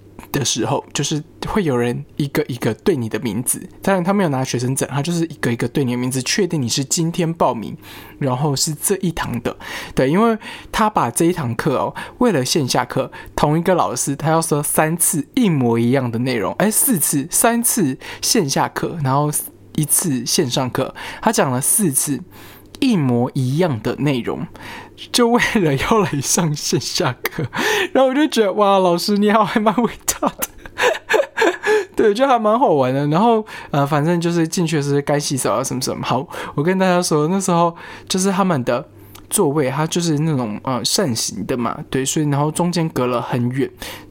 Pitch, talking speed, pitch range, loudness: 155 Hz, 270 characters per minute, 135-195 Hz, -18 LUFS